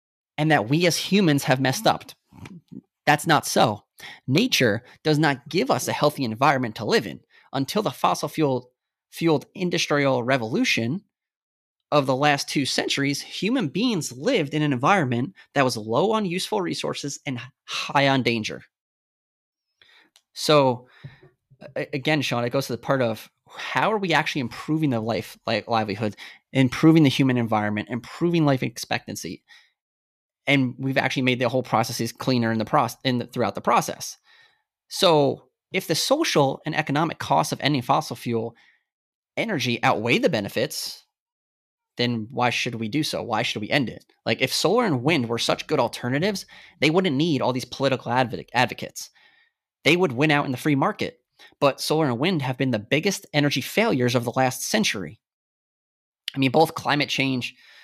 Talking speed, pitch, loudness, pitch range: 165 wpm, 140 Hz, -23 LUFS, 125-155 Hz